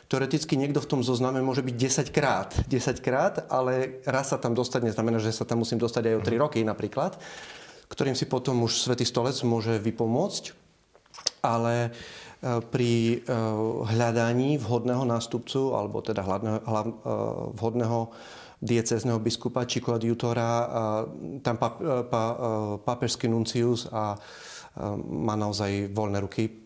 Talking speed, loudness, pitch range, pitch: 125 wpm, -27 LUFS, 115-125 Hz, 120 Hz